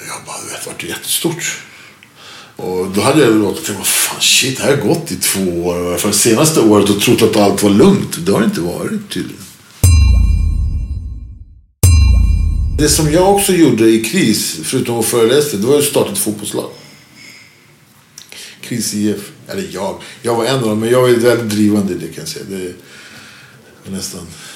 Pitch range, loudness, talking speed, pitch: 85-115 Hz, -13 LUFS, 165 wpm, 100 Hz